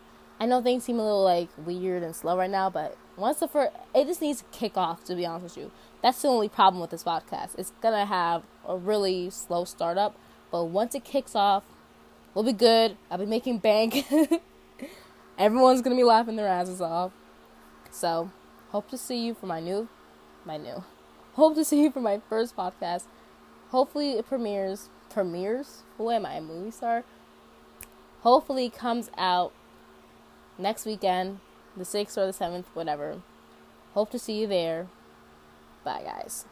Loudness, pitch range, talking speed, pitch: -27 LUFS, 170-230 Hz, 180 wpm, 195 Hz